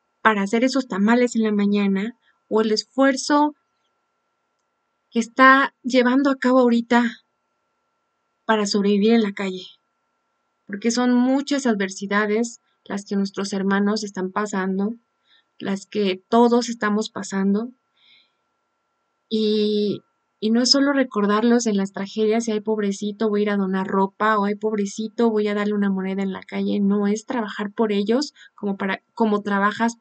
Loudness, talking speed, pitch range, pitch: -21 LUFS, 150 wpm, 200-235 Hz, 215 Hz